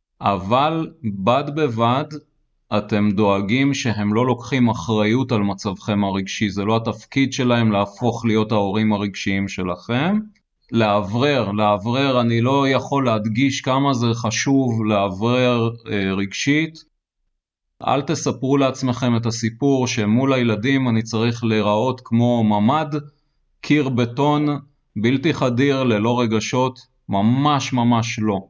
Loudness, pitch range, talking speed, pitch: -19 LUFS, 110-135 Hz, 115 wpm, 120 Hz